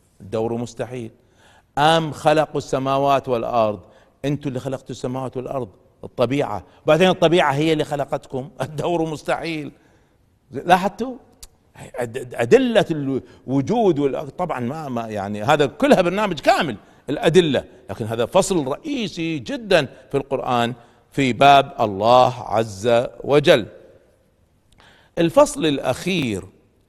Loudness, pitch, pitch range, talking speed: -20 LUFS, 135 Hz, 120-160 Hz, 100 wpm